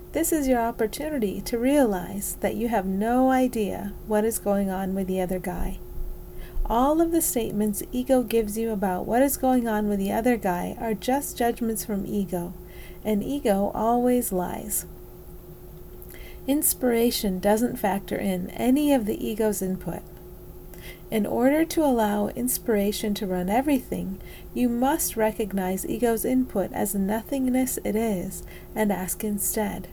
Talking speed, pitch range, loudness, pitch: 145 wpm, 195-250 Hz, -25 LUFS, 220 Hz